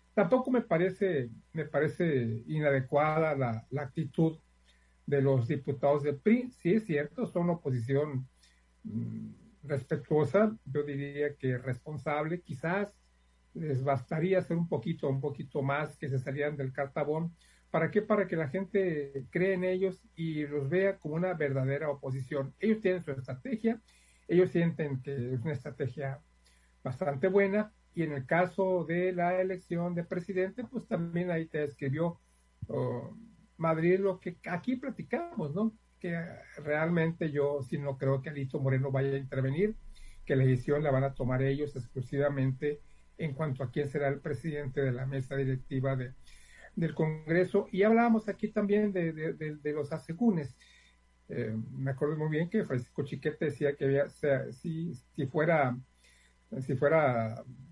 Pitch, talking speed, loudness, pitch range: 150 Hz, 160 wpm, -32 LUFS, 135-180 Hz